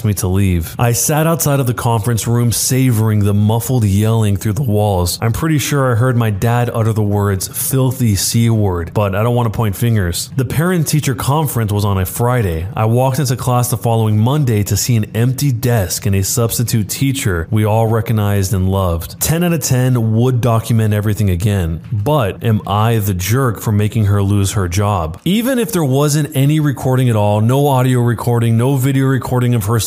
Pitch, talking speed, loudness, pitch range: 115 Hz, 200 wpm, -15 LUFS, 105-130 Hz